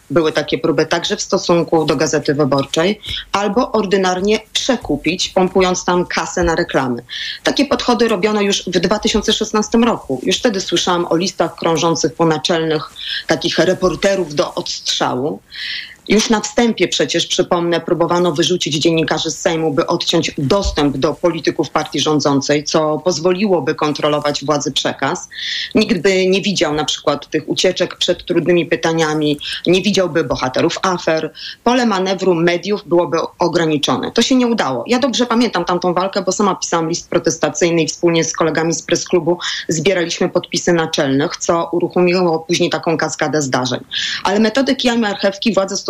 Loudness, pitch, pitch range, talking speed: -16 LUFS, 175 Hz, 160-195 Hz, 150 wpm